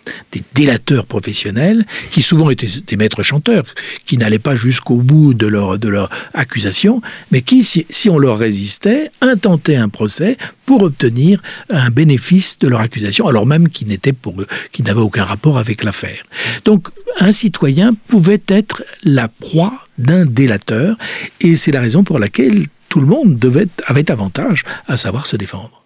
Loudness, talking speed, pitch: -12 LUFS, 170 wpm, 145 Hz